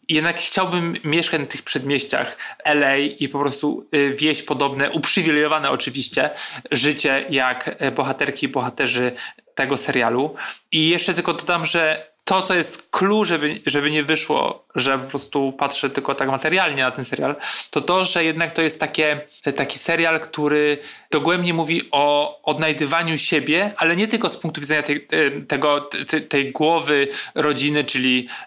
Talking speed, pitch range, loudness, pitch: 150 wpm, 140-165 Hz, -20 LUFS, 150 Hz